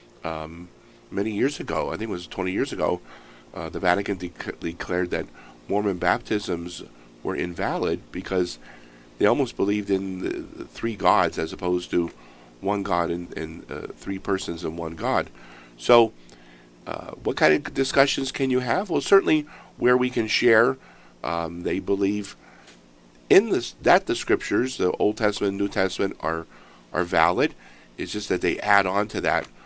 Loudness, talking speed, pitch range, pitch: -24 LUFS, 165 wpm, 70-105 Hz, 90 Hz